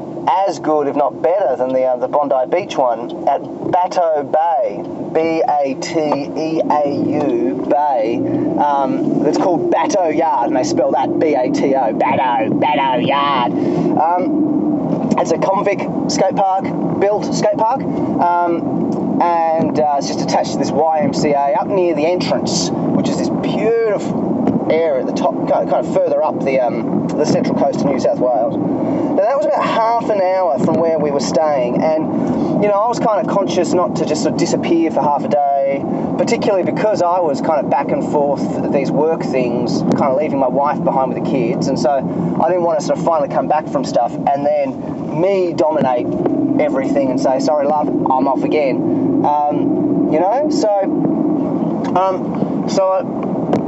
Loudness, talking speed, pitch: -16 LUFS, 180 wpm, 225 Hz